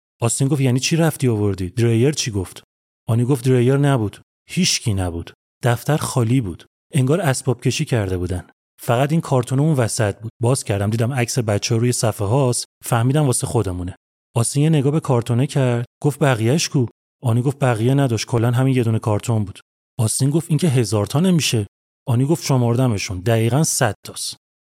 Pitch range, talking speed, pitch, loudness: 115-140 Hz, 170 wpm, 125 Hz, -19 LUFS